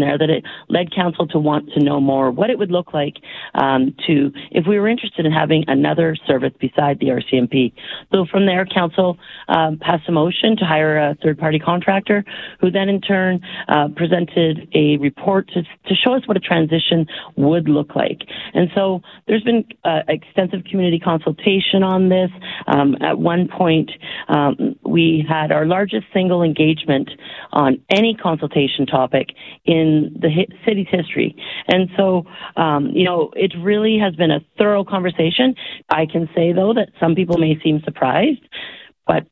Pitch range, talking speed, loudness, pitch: 155-195 Hz, 170 wpm, -17 LUFS, 170 Hz